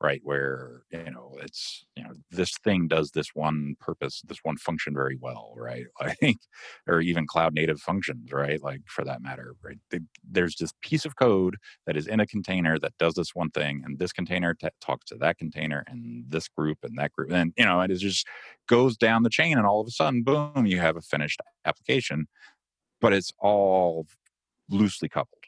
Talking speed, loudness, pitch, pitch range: 205 wpm, -26 LUFS, 80 Hz, 75-100 Hz